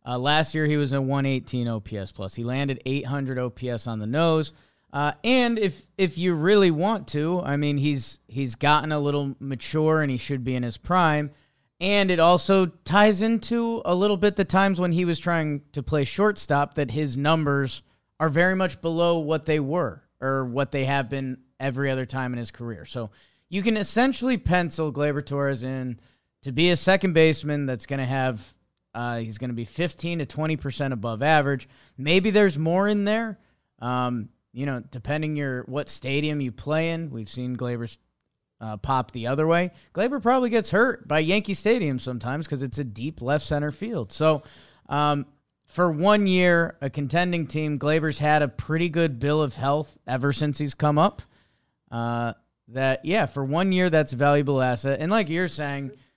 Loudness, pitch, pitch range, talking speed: -24 LUFS, 150 Hz, 130-170 Hz, 190 wpm